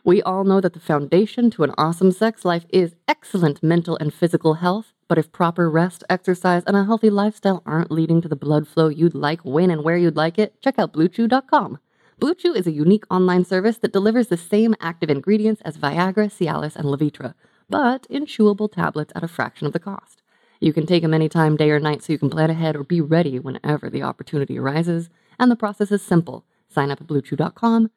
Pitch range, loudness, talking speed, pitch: 155-205 Hz, -20 LUFS, 210 wpm, 170 Hz